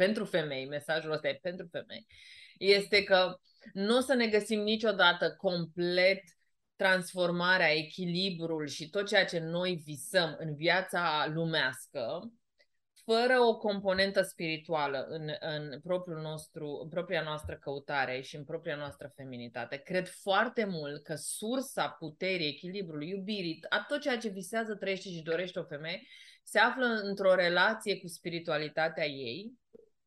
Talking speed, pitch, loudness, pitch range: 140 wpm, 180 Hz, -32 LUFS, 155-200 Hz